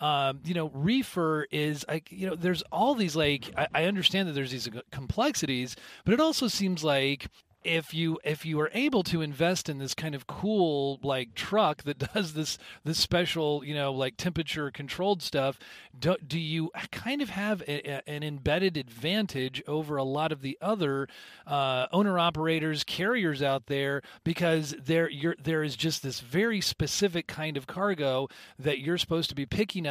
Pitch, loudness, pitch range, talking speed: 155 Hz, -29 LUFS, 140-175 Hz, 185 wpm